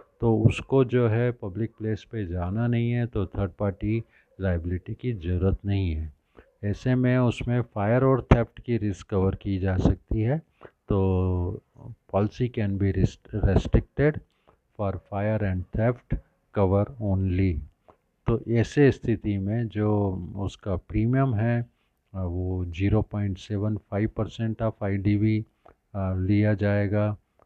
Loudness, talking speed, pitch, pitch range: -26 LUFS, 130 wpm, 105 Hz, 95-115 Hz